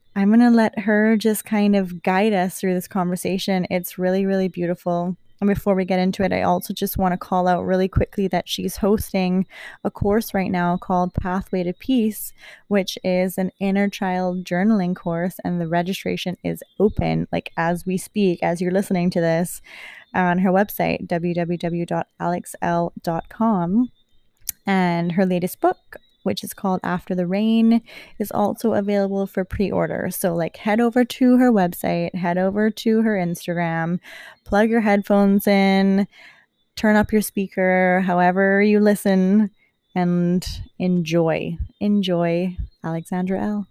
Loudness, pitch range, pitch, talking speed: -21 LUFS, 180-205 Hz, 190 Hz, 155 wpm